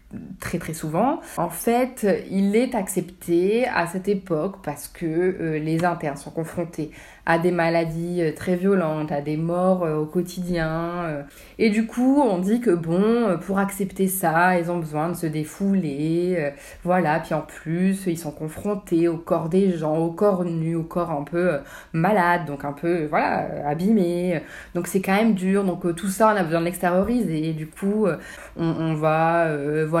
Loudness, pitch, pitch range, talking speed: -23 LUFS, 175 Hz, 160-195 Hz, 190 wpm